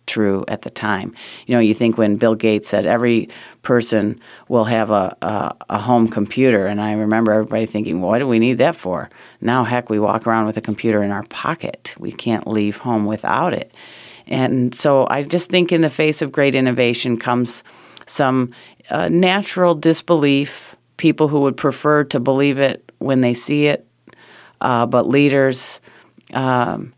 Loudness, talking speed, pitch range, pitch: -17 LUFS, 180 wpm, 110-140 Hz, 125 Hz